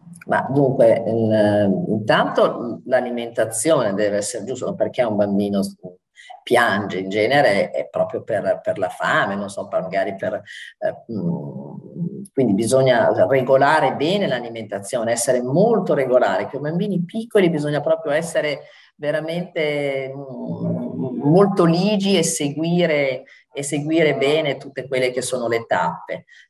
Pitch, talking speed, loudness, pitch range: 140 Hz, 120 wpm, -20 LUFS, 115-170 Hz